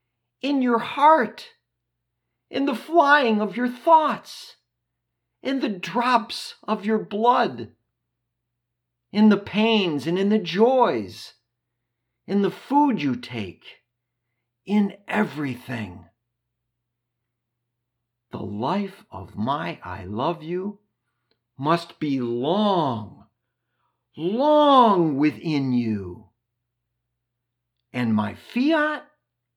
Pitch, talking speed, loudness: 125 Hz, 90 wpm, -22 LUFS